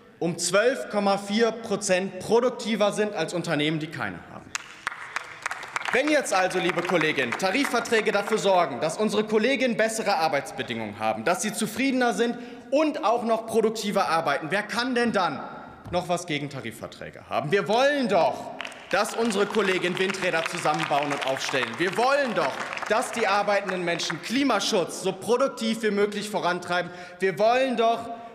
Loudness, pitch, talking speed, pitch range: -25 LUFS, 205 Hz, 145 wpm, 175-230 Hz